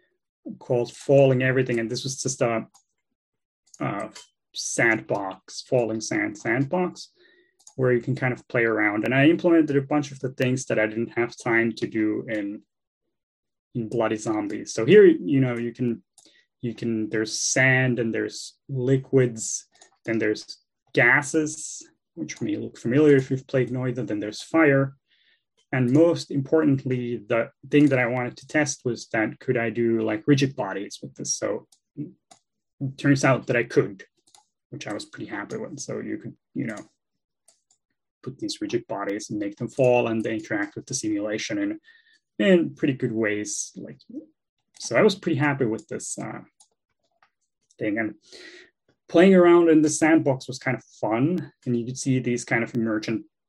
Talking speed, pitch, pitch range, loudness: 170 wpm, 130 Hz, 115-155 Hz, -23 LUFS